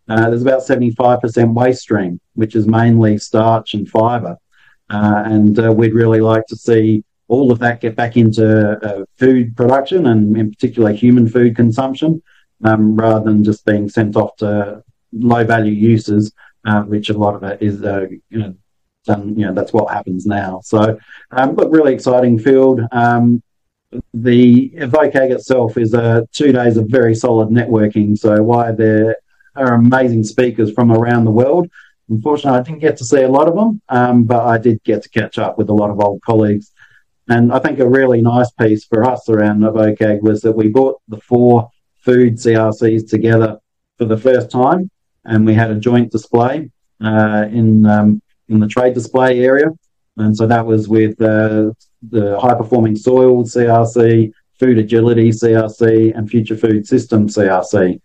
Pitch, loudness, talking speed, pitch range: 115 Hz, -13 LUFS, 180 wpm, 110-125 Hz